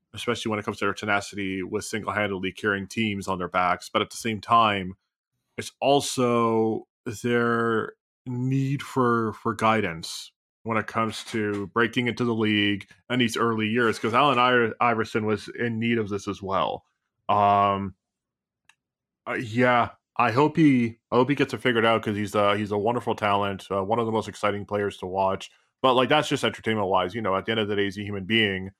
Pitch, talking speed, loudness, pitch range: 110 Hz, 200 wpm, -24 LUFS, 100-120 Hz